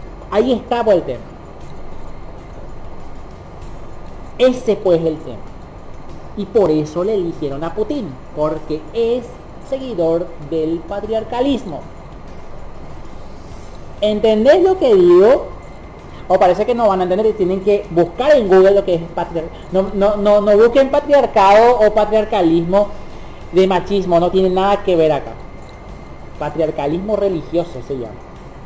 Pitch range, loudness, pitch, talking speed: 160-220 Hz, -15 LUFS, 190 Hz, 135 wpm